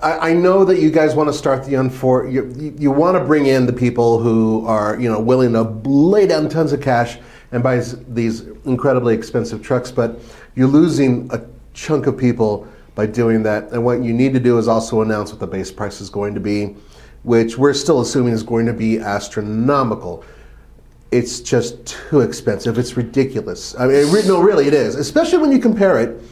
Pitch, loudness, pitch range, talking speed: 120 Hz, -16 LUFS, 115-140 Hz, 205 wpm